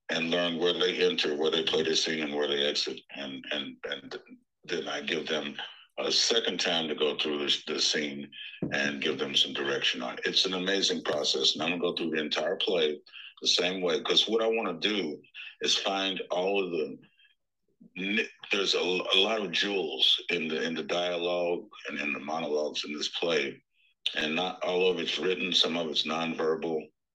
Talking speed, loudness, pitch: 205 wpm, -28 LUFS, 95 Hz